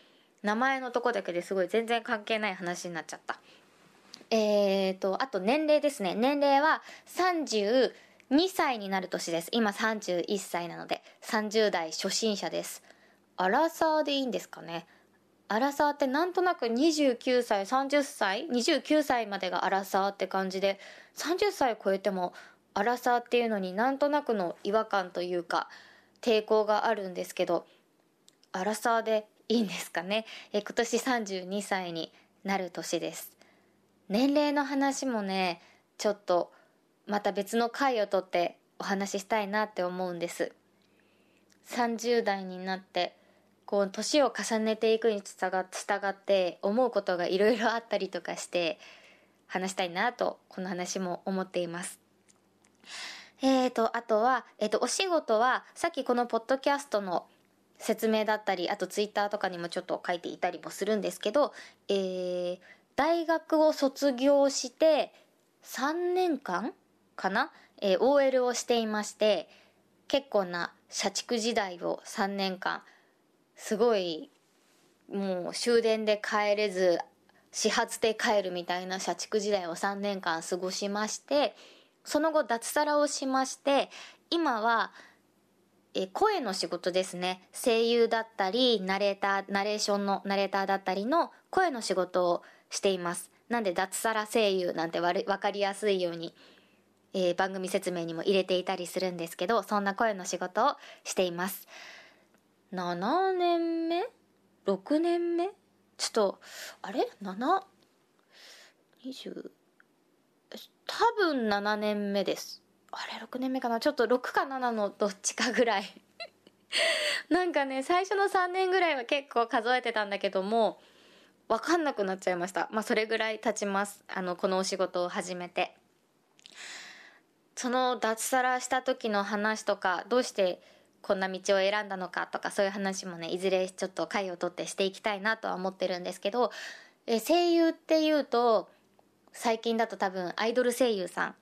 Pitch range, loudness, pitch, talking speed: 190-255 Hz, -30 LUFS, 210 Hz, 285 characters per minute